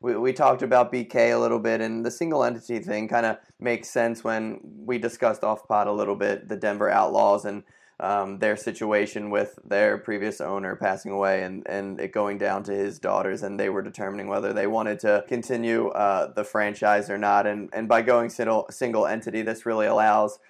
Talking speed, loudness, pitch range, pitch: 200 wpm, -25 LUFS, 105-115 Hz, 110 Hz